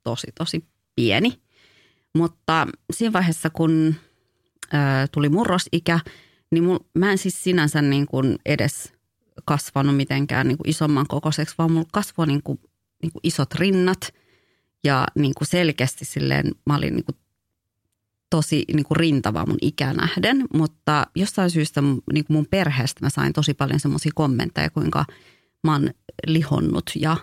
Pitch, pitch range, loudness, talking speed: 155 Hz, 140-165 Hz, -22 LUFS, 150 wpm